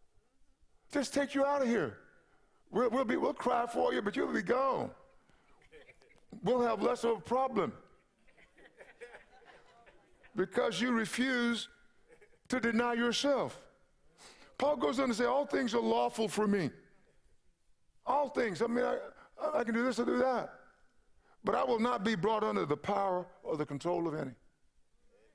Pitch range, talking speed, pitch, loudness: 220-265 Hz, 155 wpm, 240 Hz, -33 LUFS